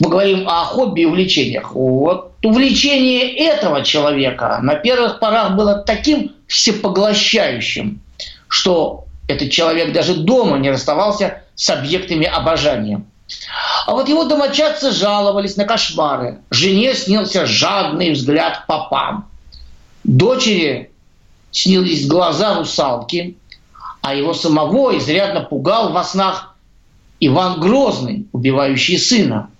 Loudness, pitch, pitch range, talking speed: -15 LUFS, 185 Hz, 155-220 Hz, 105 wpm